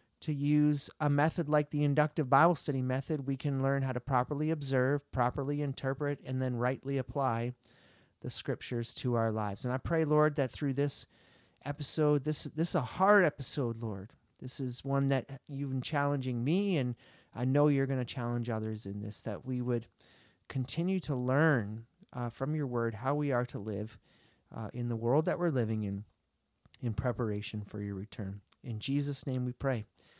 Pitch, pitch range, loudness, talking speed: 130 Hz, 120-145 Hz, -33 LUFS, 185 wpm